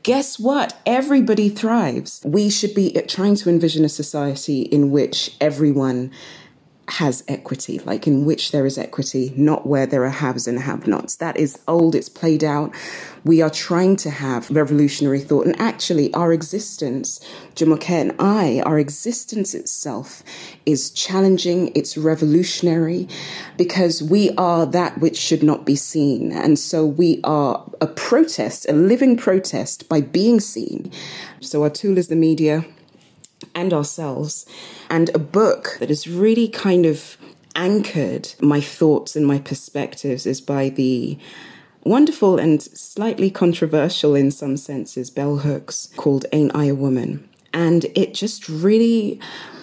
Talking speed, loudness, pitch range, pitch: 150 wpm, -19 LUFS, 145-190 Hz, 160 Hz